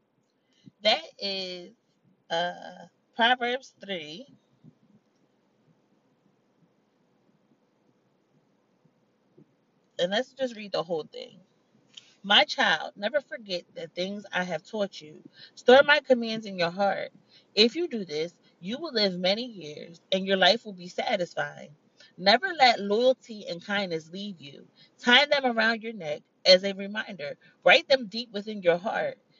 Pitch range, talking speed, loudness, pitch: 180-250 Hz, 130 wpm, -25 LUFS, 210 Hz